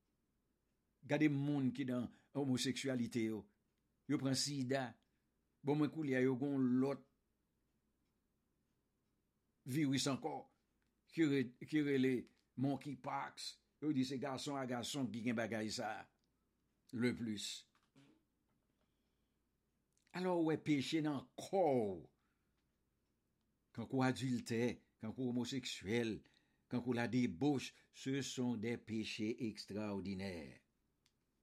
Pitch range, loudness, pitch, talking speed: 115-140 Hz, -41 LUFS, 130 Hz, 105 wpm